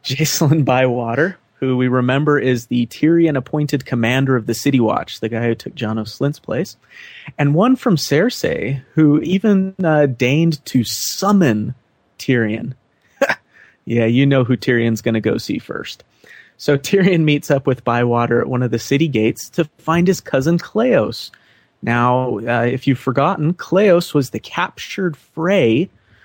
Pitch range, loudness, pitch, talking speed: 120-155 Hz, -17 LUFS, 135 Hz, 160 wpm